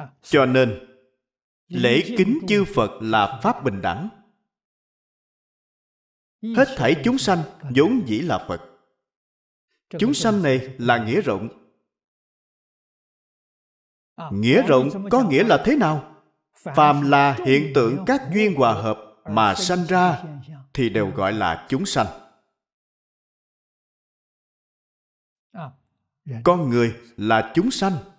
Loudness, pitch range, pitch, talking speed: -20 LUFS, 120-195 Hz, 145 Hz, 115 wpm